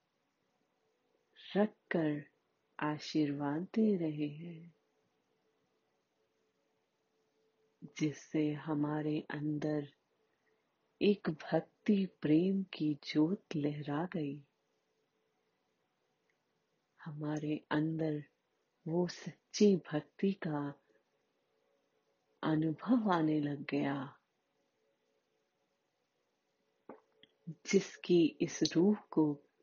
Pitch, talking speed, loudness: 150 Hz, 60 wpm, -35 LUFS